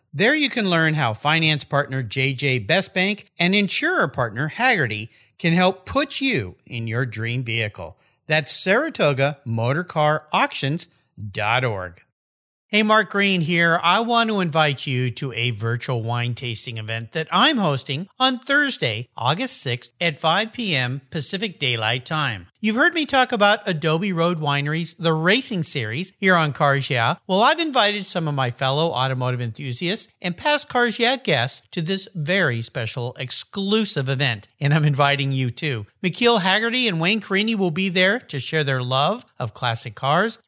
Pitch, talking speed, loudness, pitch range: 155 Hz, 160 wpm, -20 LUFS, 125-195 Hz